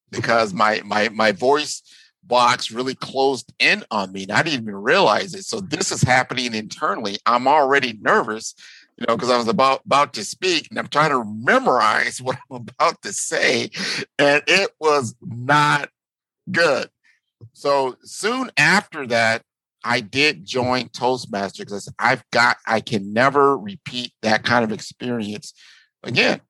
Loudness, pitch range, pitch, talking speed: -19 LUFS, 115-145 Hz, 125 Hz, 155 wpm